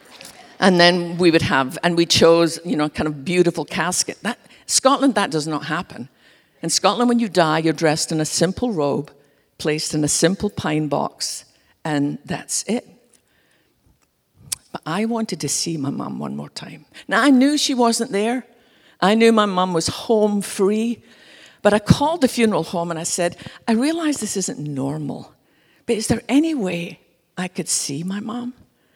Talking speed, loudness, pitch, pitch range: 180 wpm, -19 LUFS, 180 Hz, 155-225 Hz